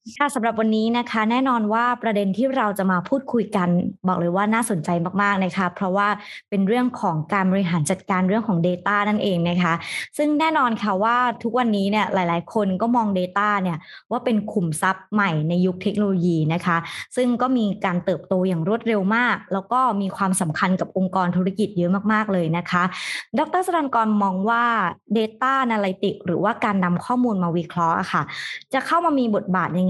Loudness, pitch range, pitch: -21 LUFS, 185-230 Hz, 200 Hz